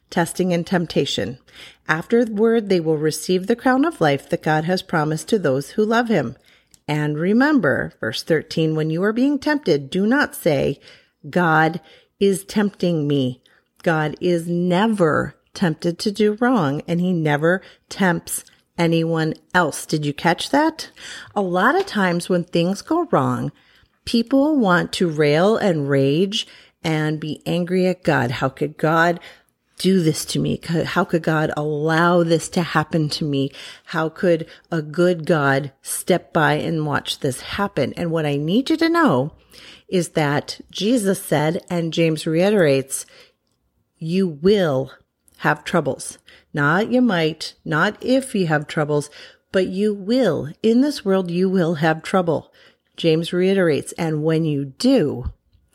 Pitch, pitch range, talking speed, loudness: 175 Hz, 155-200 Hz, 155 wpm, -20 LUFS